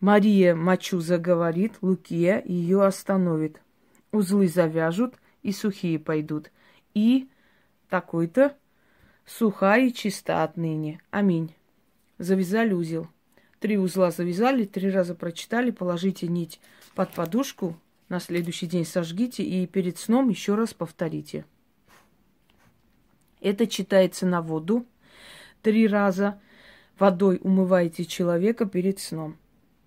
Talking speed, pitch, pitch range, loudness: 100 wpm, 190 Hz, 175-205 Hz, -25 LUFS